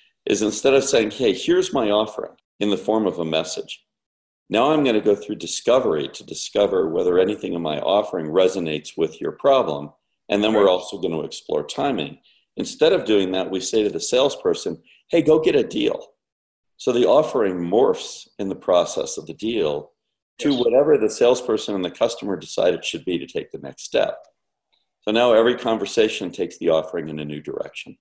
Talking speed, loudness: 195 wpm, -21 LUFS